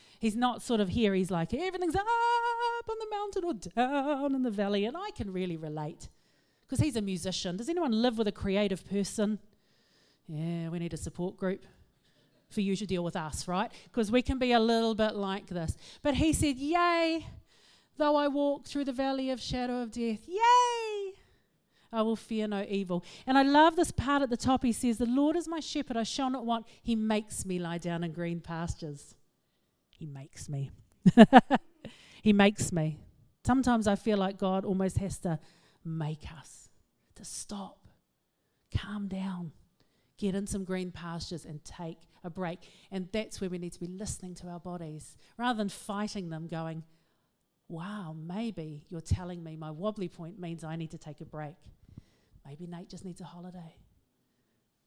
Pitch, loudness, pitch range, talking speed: 200 Hz, -31 LUFS, 170-250 Hz, 185 wpm